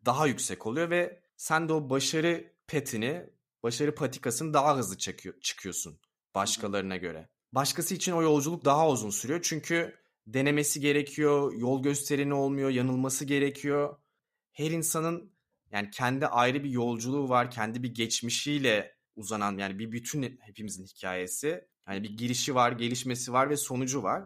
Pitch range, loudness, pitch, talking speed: 120-150 Hz, -29 LUFS, 135 Hz, 145 wpm